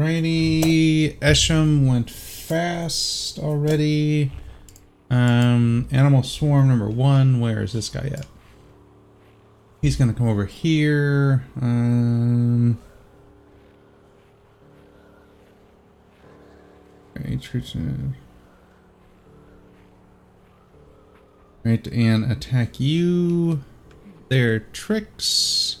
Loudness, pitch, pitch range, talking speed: -20 LUFS, 120 Hz, 105-145 Hz, 65 wpm